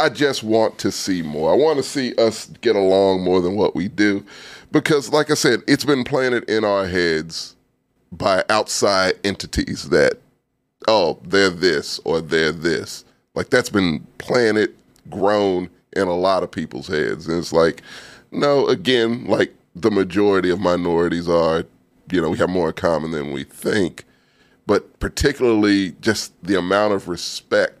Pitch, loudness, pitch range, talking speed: 100 Hz, -19 LUFS, 85-115 Hz, 165 wpm